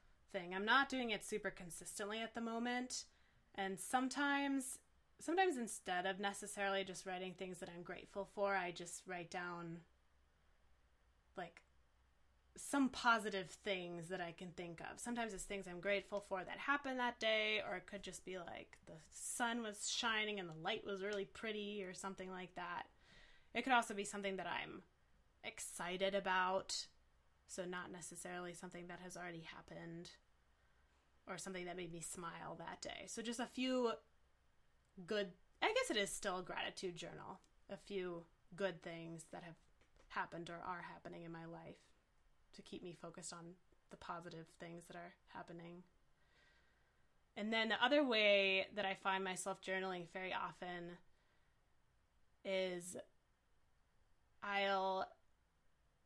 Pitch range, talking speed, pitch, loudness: 170-205 Hz, 150 wpm, 185 Hz, -43 LUFS